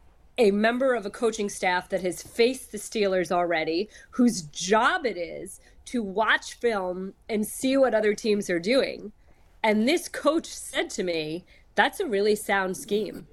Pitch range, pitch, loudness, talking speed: 185-235 Hz, 210 Hz, -26 LUFS, 165 wpm